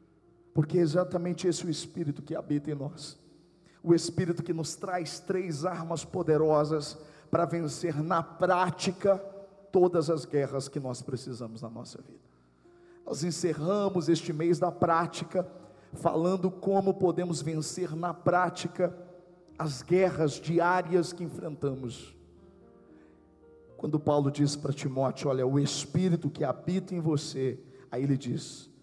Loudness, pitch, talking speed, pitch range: -30 LUFS, 165 Hz, 135 wpm, 145-180 Hz